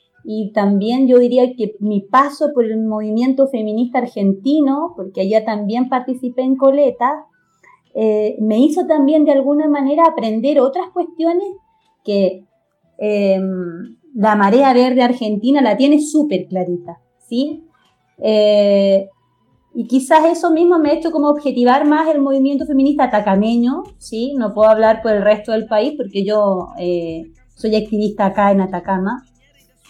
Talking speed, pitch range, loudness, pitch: 140 wpm, 210-285 Hz, -15 LUFS, 240 Hz